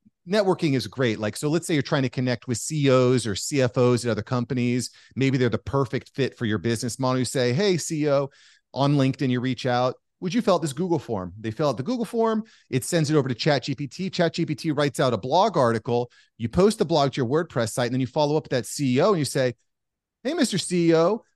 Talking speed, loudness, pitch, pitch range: 235 wpm, -24 LUFS, 135 Hz, 125-165 Hz